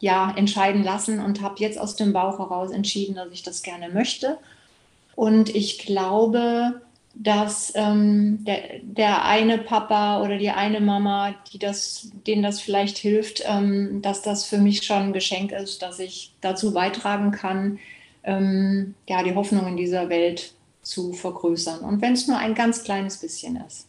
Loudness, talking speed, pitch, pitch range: -23 LUFS, 170 wpm, 200 Hz, 190-210 Hz